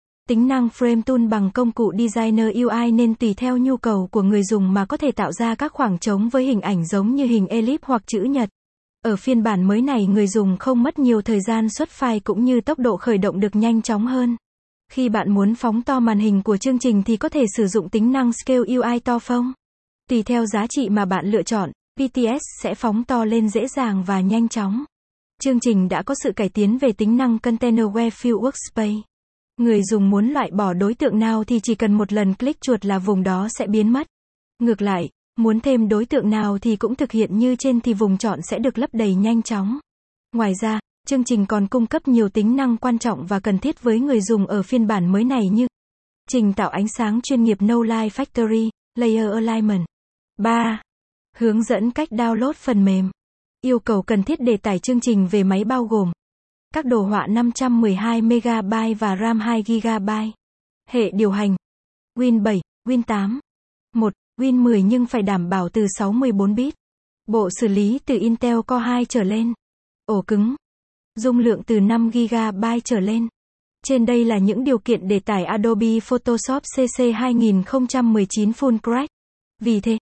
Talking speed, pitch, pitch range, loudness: 200 wpm, 230 Hz, 210-245 Hz, -20 LUFS